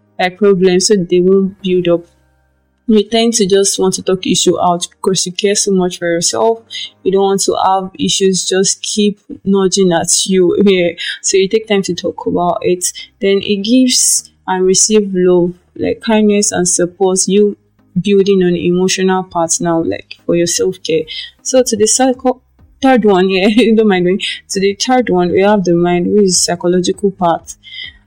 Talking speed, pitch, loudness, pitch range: 190 wpm, 190 Hz, -12 LUFS, 180-210 Hz